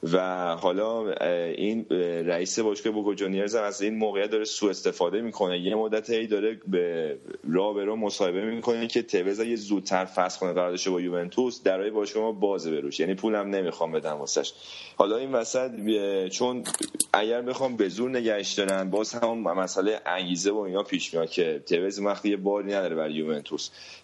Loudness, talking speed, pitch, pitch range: -27 LUFS, 165 wpm, 105 Hz, 95-120 Hz